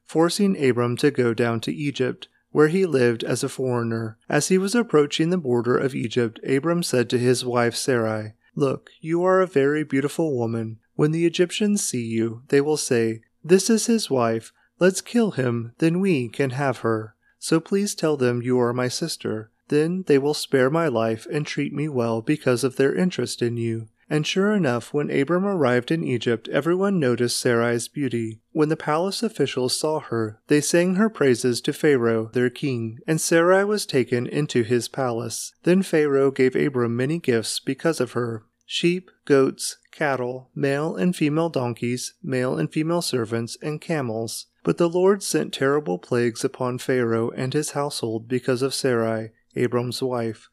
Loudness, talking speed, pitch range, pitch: -23 LUFS, 175 wpm, 120-160 Hz, 135 Hz